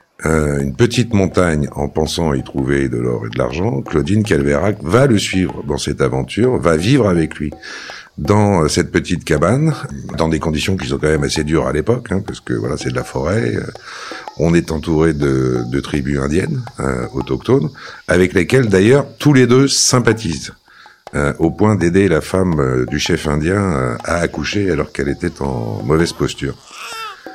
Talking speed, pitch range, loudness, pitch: 185 wpm, 70-100 Hz, -16 LUFS, 80 Hz